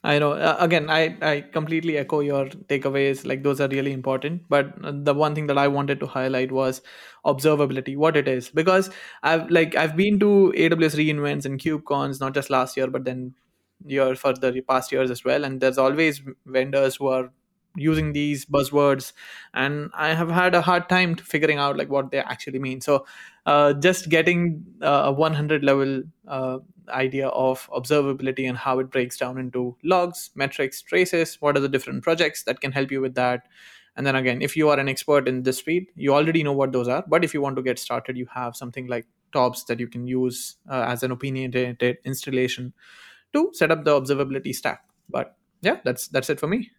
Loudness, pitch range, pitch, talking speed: -23 LUFS, 130-155 Hz, 140 Hz, 200 wpm